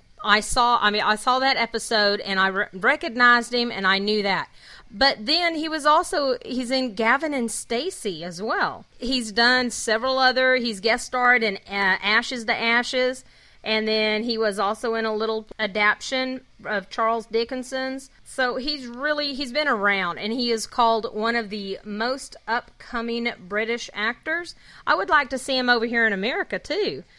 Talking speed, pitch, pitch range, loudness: 180 wpm, 235 Hz, 215-260 Hz, -22 LUFS